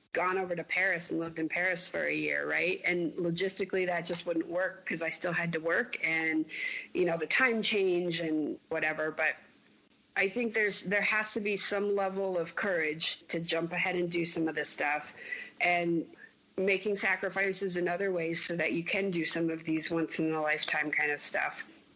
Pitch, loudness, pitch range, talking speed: 175 Hz, -31 LUFS, 160-195 Hz, 200 wpm